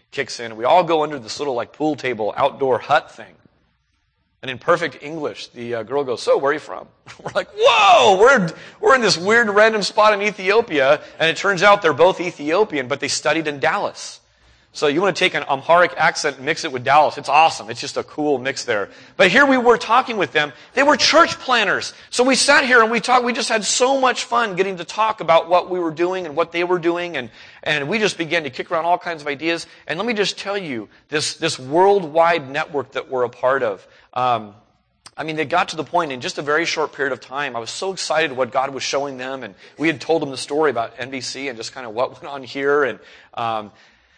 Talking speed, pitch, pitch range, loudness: 245 wpm, 160 Hz, 140-195 Hz, -18 LUFS